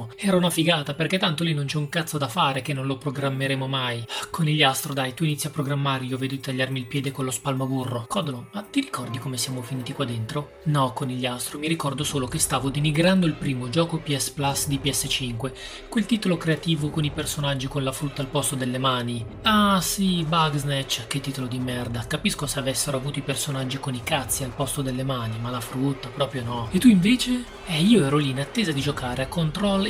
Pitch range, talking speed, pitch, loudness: 130-160 Hz, 215 wpm, 140 Hz, -24 LUFS